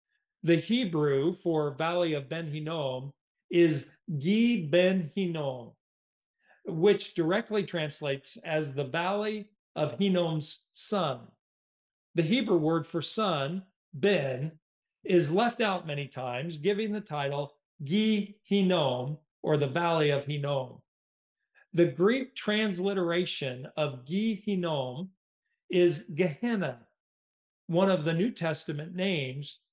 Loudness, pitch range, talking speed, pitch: -29 LUFS, 150-200 Hz, 110 wpm, 170 Hz